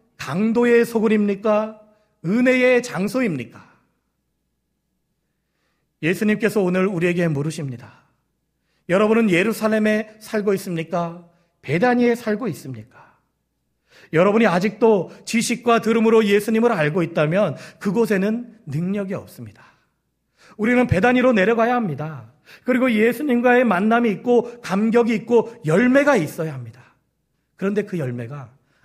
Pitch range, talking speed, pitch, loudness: 165-230 Hz, 290 characters per minute, 210 Hz, -19 LUFS